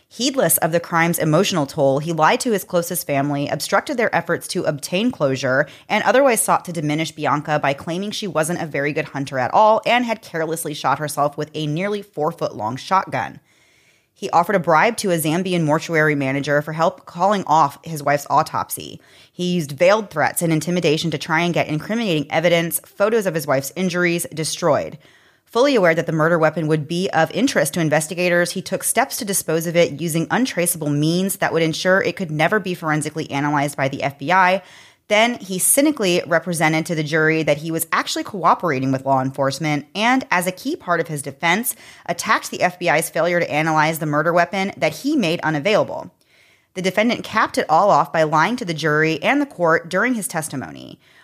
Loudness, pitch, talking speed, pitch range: -19 LUFS, 165 Hz, 195 wpm, 155-190 Hz